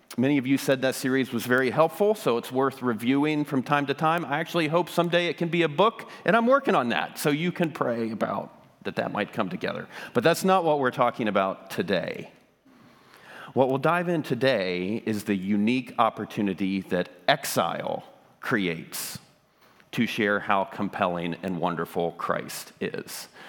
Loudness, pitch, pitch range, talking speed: -26 LUFS, 130 Hz, 105-160 Hz, 175 wpm